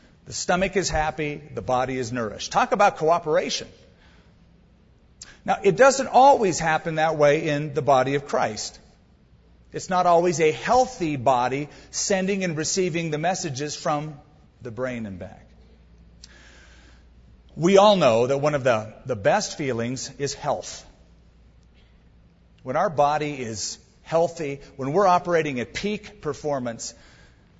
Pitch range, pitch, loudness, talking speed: 115-170 Hz, 145 Hz, -23 LUFS, 135 wpm